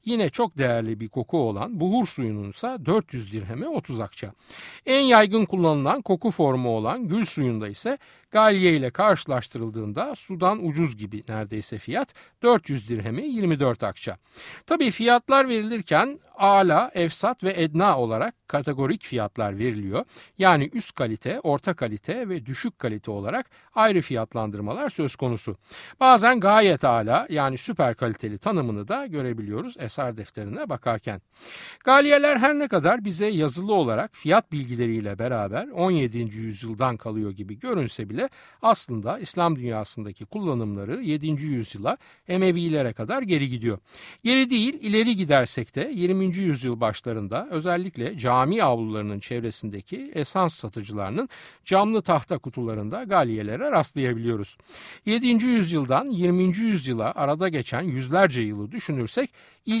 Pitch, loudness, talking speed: 145 Hz, -24 LUFS, 125 wpm